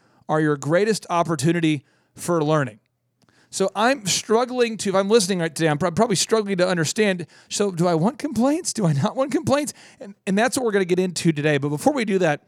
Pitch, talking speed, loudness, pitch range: 185 Hz, 210 wpm, -21 LUFS, 160-220 Hz